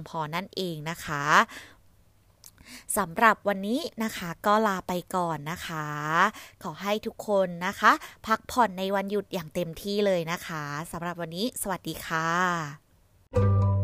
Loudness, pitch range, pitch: -27 LUFS, 155-205 Hz, 175 Hz